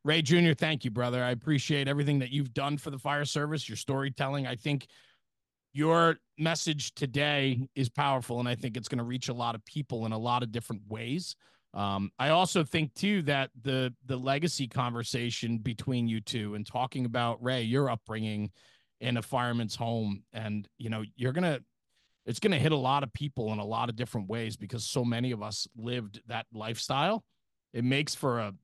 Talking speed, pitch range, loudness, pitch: 195 wpm, 115-140 Hz, -31 LUFS, 125 Hz